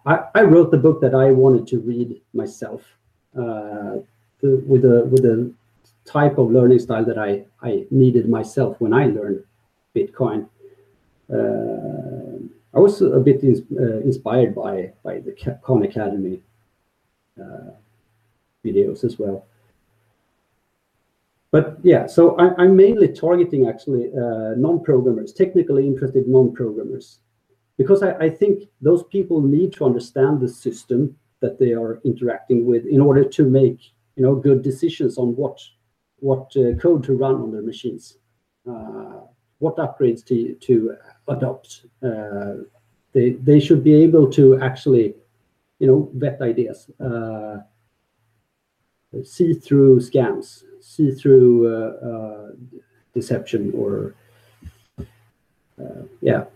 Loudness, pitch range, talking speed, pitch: -17 LUFS, 115-145 Hz, 135 wpm, 125 Hz